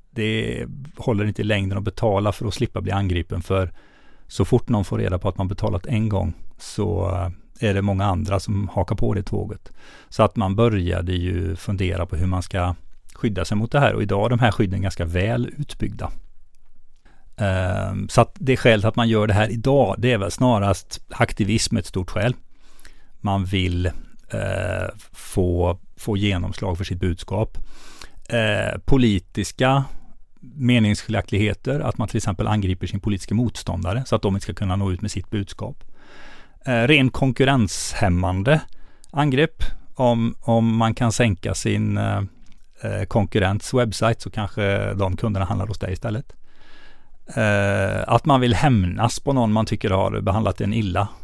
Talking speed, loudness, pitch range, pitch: 160 wpm, -22 LUFS, 95-115 Hz, 105 Hz